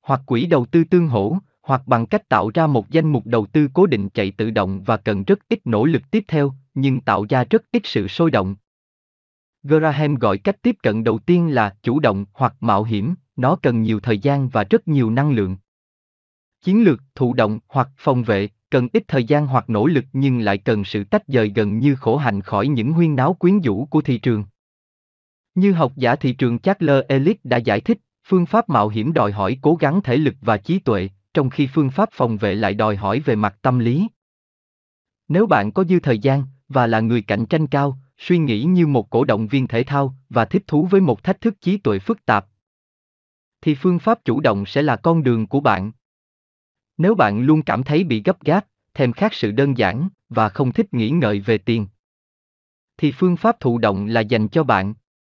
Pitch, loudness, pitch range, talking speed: 130 Hz, -19 LUFS, 110-160 Hz, 220 wpm